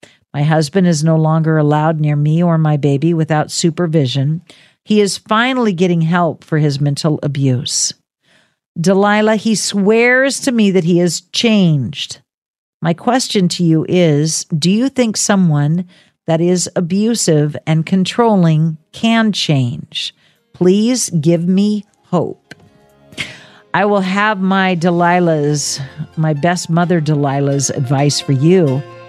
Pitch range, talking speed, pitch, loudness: 150-195 Hz, 130 wpm, 170 Hz, -14 LUFS